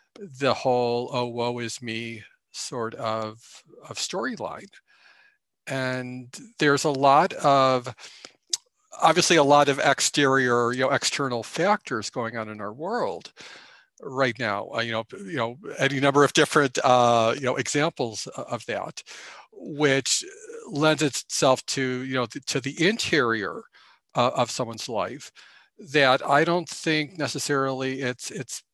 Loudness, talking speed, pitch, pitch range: -24 LUFS, 140 wpm, 135 Hz, 120-150 Hz